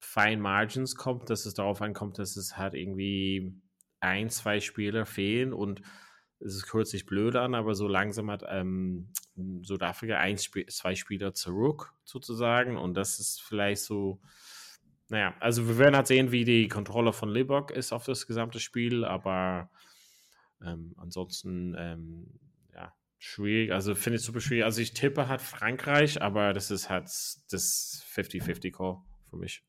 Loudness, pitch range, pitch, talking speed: -30 LUFS, 95-115 Hz, 105 Hz, 155 wpm